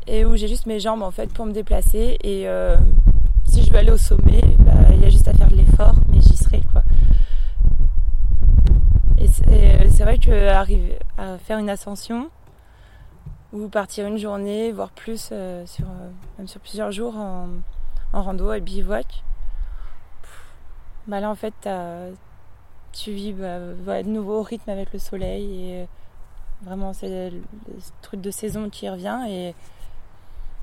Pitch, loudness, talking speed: 185 Hz, -20 LUFS, 170 wpm